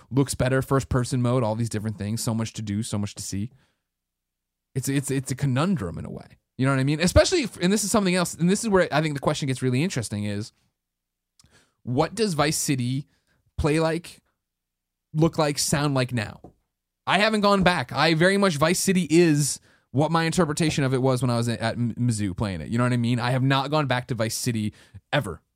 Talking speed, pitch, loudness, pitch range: 230 wpm, 130 Hz, -24 LUFS, 110-160 Hz